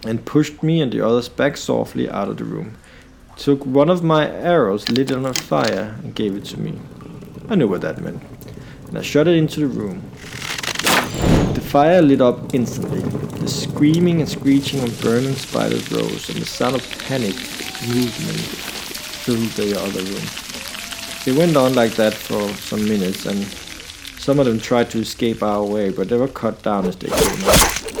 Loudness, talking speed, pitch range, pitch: -19 LUFS, 190 wpm, 110-145 Hz, 125 Hz